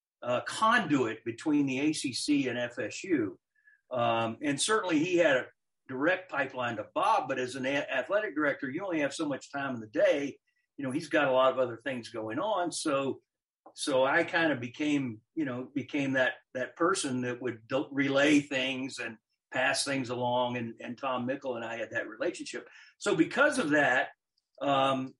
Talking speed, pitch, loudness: 185 wpm, 140 Hz, -30 LUFS